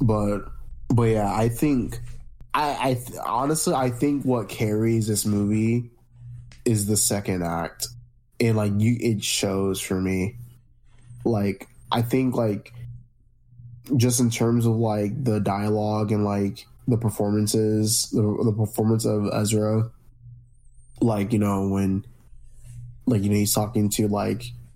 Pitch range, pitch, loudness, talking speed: 105-120 Hz, 115 Hz, -24 LUFS, 140 wpm